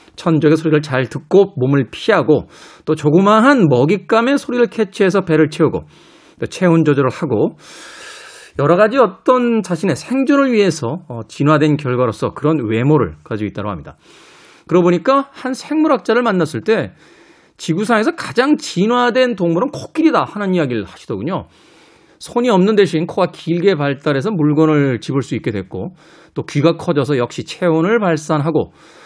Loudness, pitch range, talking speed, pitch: -15 LUFS, 145-215 Hz, 330 characters per minute, 165 Hz